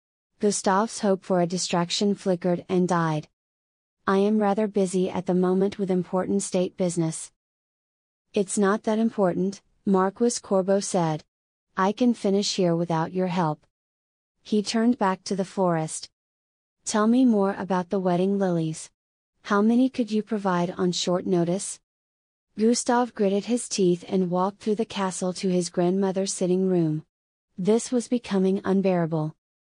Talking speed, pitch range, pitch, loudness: 145 wpm, 175-205 Hz, 190 Hz, -24 LUFS